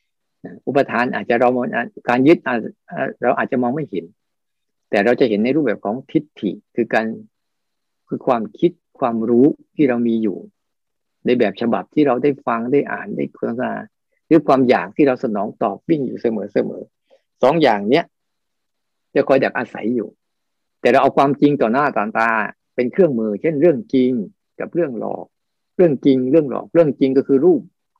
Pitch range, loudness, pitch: 125-170 Hz, -18 LUFS, 140 Hz